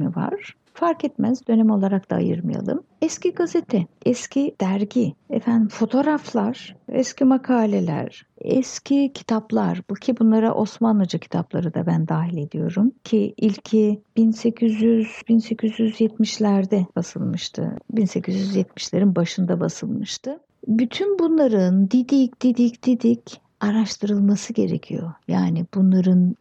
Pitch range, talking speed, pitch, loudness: 195-245 Hz, 100 wpm, 220 Hz, -21 LUFS